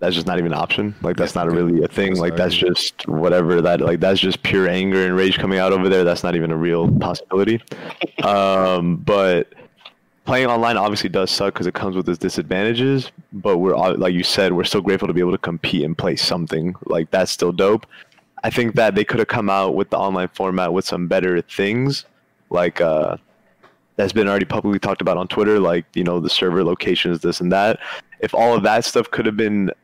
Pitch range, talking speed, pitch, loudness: 90-100 Hz, 225 wpm, 95 Hz, -18 LUFS